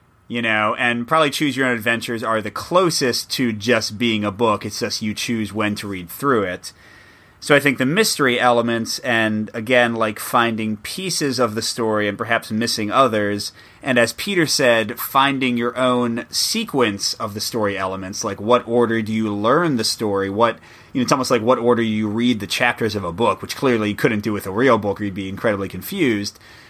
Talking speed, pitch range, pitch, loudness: 205 wpm, 105-125 Hz, 115 Hz, -19 LUFS